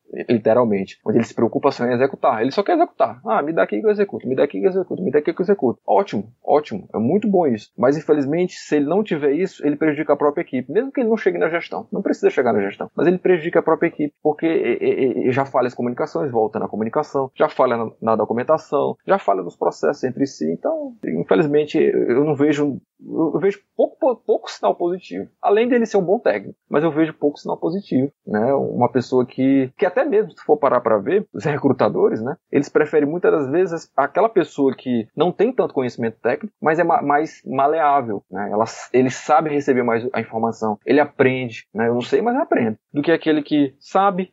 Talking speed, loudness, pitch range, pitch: 220 wpm, -19 LUFS, 130-200 Hz, 150 Hz